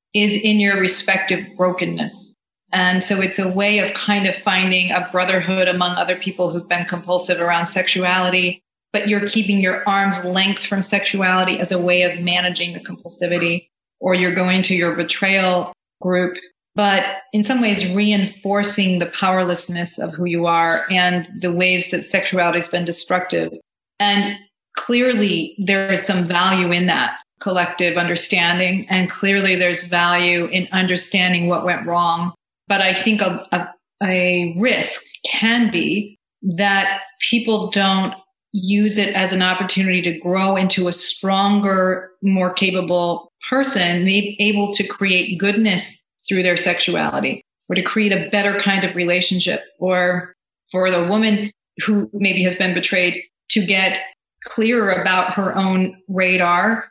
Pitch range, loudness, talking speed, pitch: 180-200 Hz, -17 LUFS, 150 wpm, 185 Hz